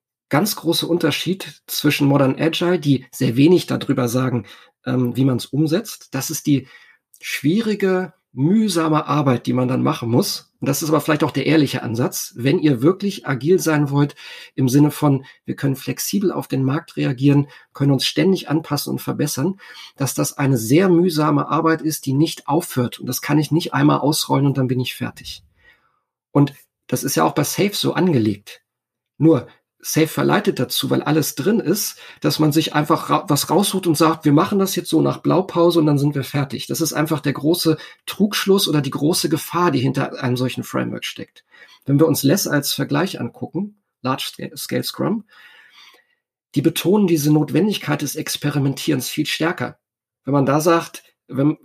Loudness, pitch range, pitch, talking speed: -19 LUFS, 135-165 Hz, 150 Hz, 180 wpm